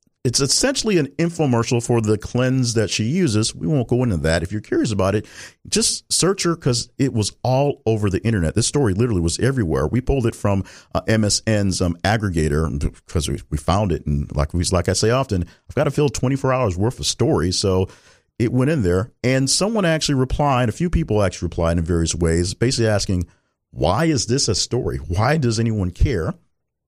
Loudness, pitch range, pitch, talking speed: -20 LUFS, 90-130 Hz, 110 Hz, 205 wpm